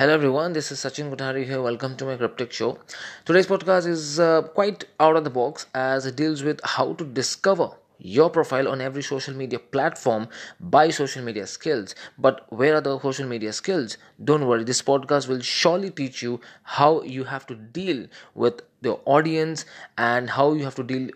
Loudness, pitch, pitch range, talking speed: -23 LUFS, 135 Hz, 130-155 Hz, 195 wpm